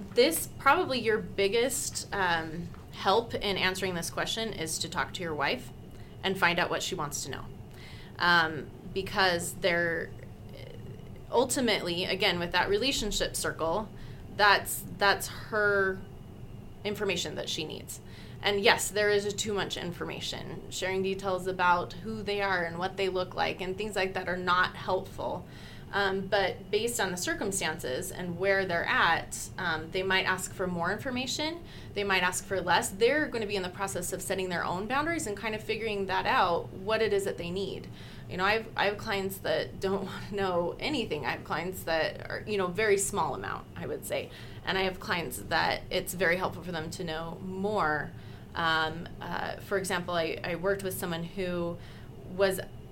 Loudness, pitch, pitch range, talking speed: -30 LUFS, 185 Hz, 170-200 Hz, 185 wpm